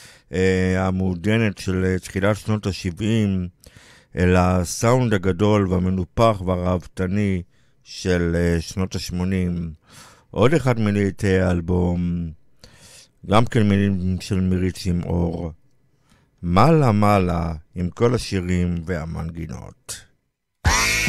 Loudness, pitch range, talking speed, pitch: -21 LUFS, 90-105 Hz, 85 wpm, 95 Hz